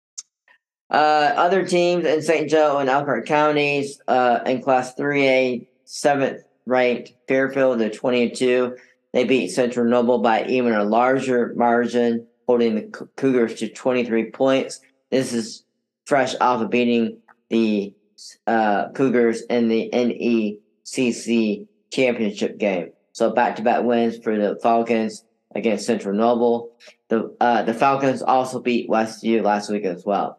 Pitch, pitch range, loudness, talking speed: 120 Hz, 115-130 Hz, -20 LUFS, 140 wpm